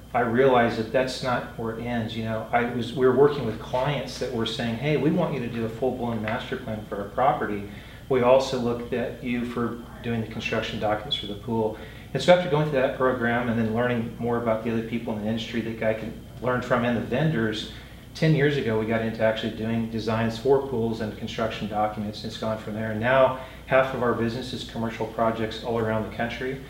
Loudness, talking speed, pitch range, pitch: -25 LUFS, 235 wpm, 110-125 Hz, 115 Hz